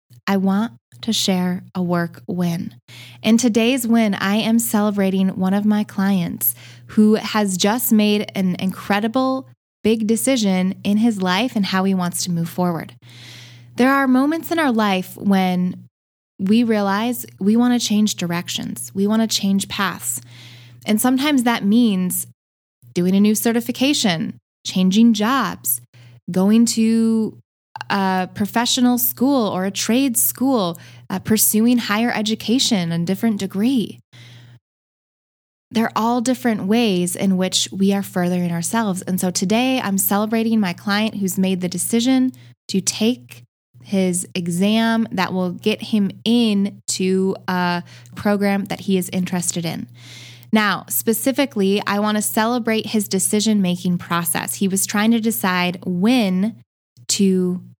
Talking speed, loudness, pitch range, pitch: 140 wpm, -19 LUFS, 180-225 Hz, 200 Hz